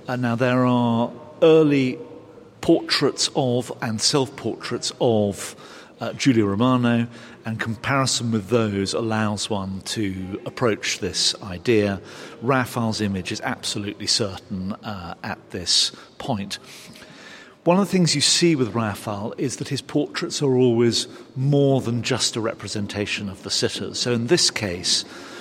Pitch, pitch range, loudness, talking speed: 115 Hz, 105-130 Hz, -22 LUFS, 140 wpm